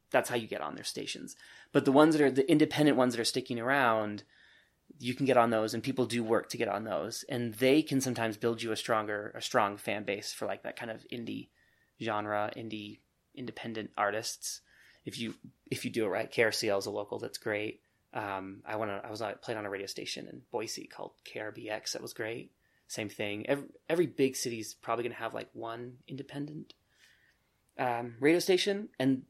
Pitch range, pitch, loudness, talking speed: 110-135 Hz, 120 Hz, -32 LUFS, 215 wpm